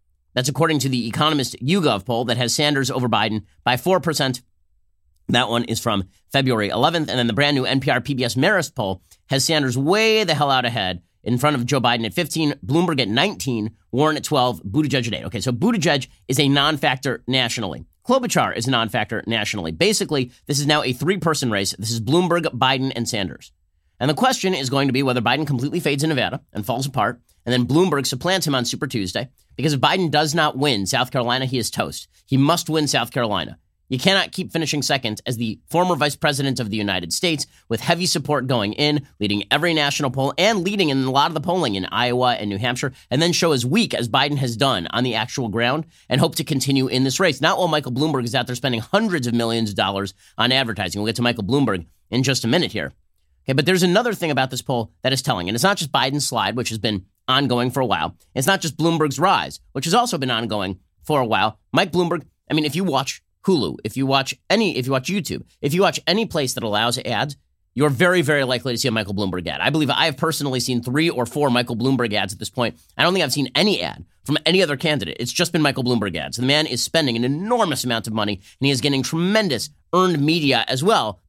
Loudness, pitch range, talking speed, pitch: -20 LUFS, 115-155 Hz, 235 wpm, 130 Hz